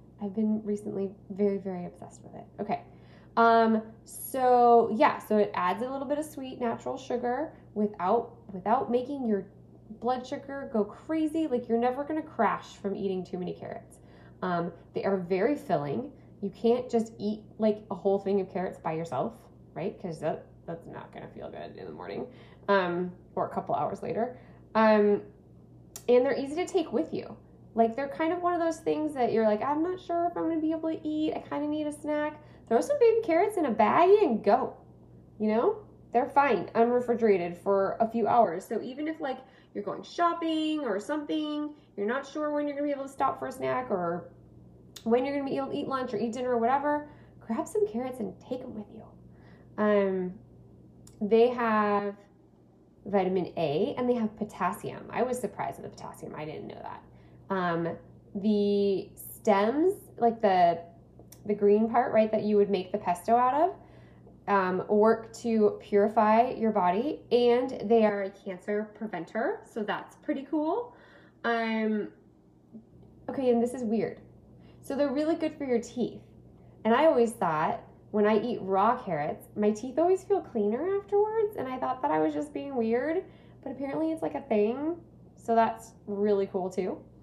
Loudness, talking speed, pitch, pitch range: -28 LUFS, 190 wpm, 225 Hz, 200-275 Hz